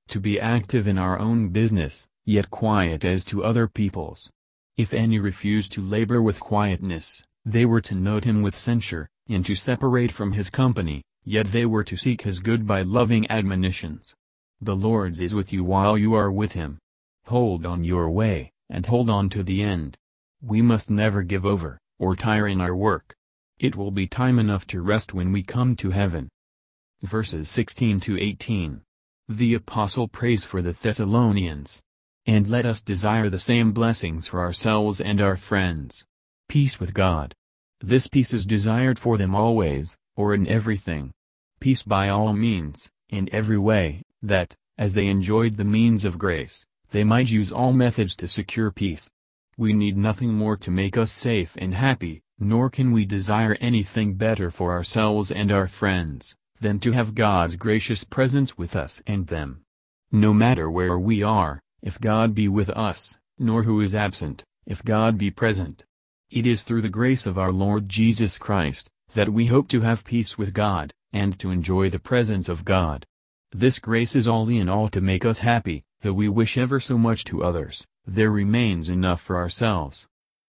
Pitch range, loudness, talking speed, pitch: 95-115 Hz, -23 LUFS, 180 wpm, 105 Hz